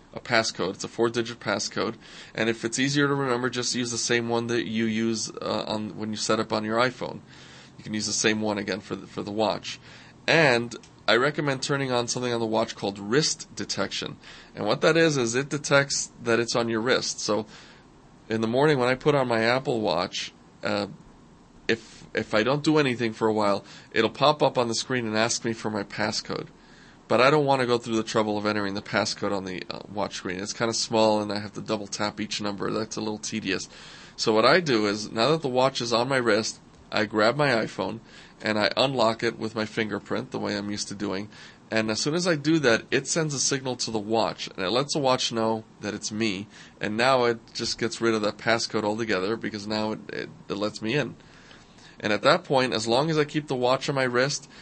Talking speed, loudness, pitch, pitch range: 245 wpm, -25 LUFS, 115 Hz, 110-125 Hz